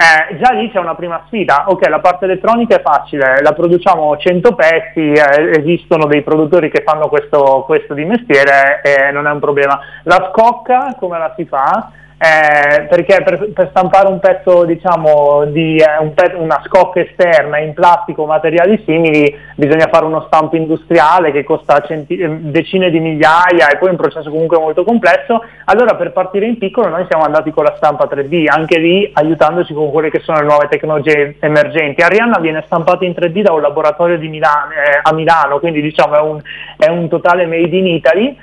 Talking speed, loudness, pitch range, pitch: 190 wpm, -11 LUFS, 150-180 Hz, 160 Hz